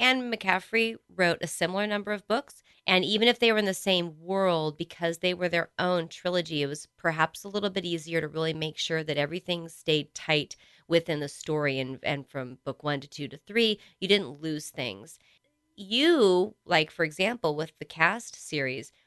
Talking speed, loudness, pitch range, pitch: 195 wpm, -28 LUFS, 155-195 Hz, 170 Hz